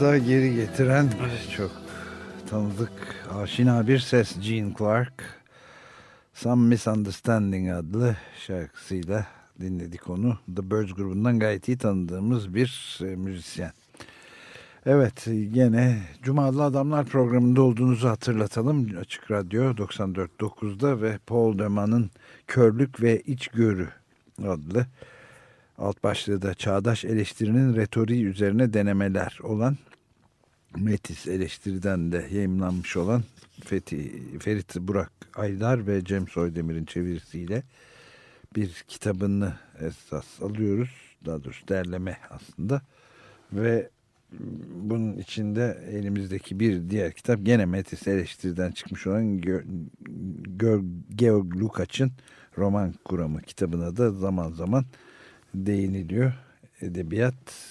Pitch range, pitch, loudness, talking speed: 95-120 Hz, 105 Hz, -26 LUFS, 100 wpm